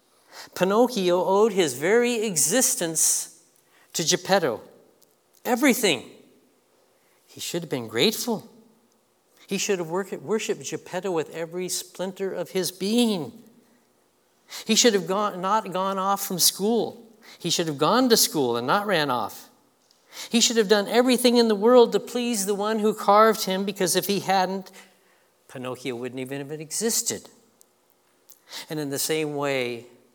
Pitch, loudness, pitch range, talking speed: 200 Hz, -23 LUFS, 175-225 Hz, 145 wpm